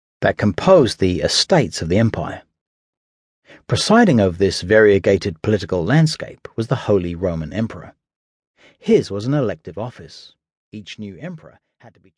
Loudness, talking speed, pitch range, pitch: -17 LUFS, 145 wpm, 90-115 Hz, 100 Hz